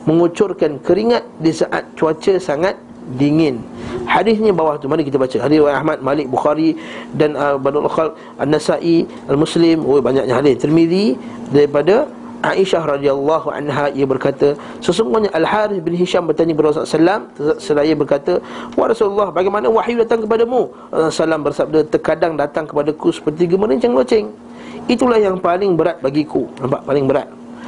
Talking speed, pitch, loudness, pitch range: 145 wpm, 160 Hz, -16 LUFS, 145-195 Hz